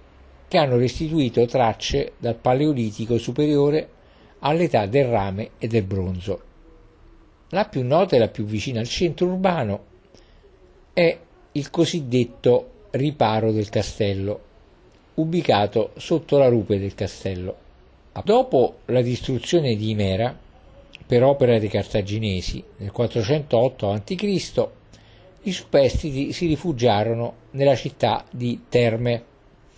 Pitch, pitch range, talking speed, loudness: 120 Hz, 105-145 Hz, 110 wpm, -22 LUFS